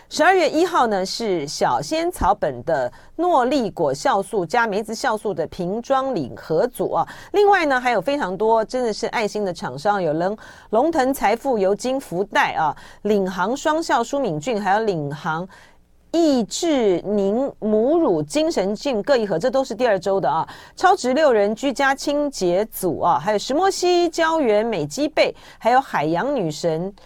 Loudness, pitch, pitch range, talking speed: -20 LUFS, 230 Hz, 200-290 Hz, 250 characters per minute